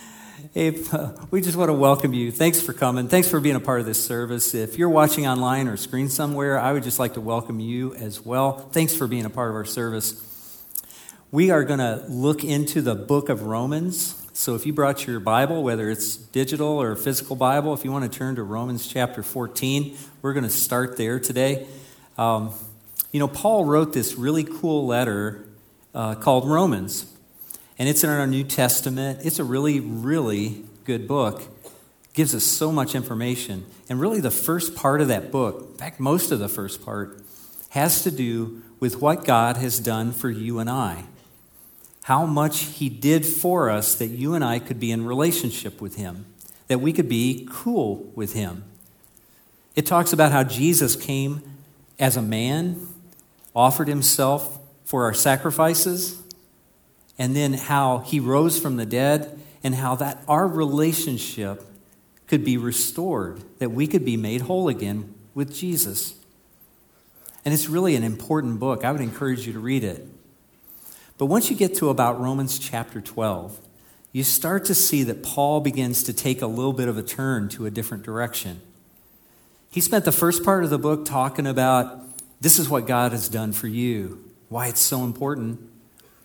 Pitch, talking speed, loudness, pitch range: 130 Hz, 180 wpm, -22 LUFS, 115-150 Hz